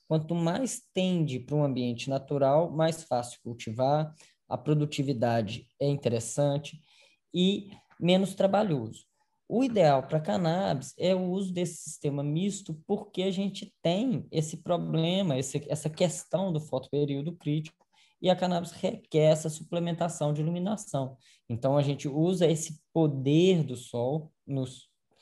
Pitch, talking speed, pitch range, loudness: 160 Hz, 135 wpm, 140-180 Hz, -29 LUFS